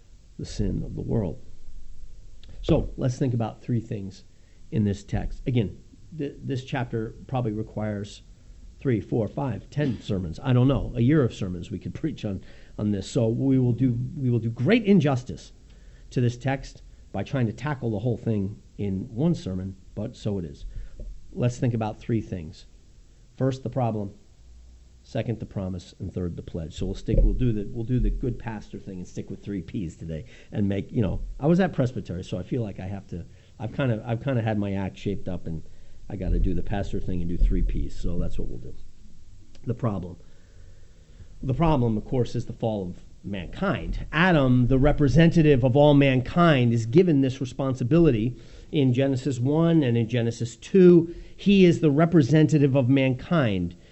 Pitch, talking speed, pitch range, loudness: 115 Hz, 195 wpm, 95-130 Hz, -25 LUFS